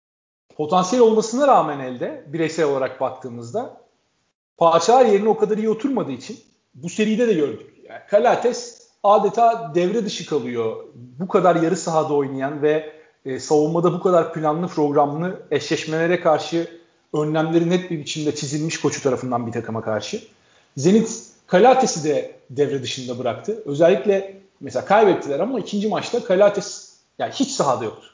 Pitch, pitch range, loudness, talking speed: 170 Hz, 145-210 Hz, -20 LUFS, 135 wpm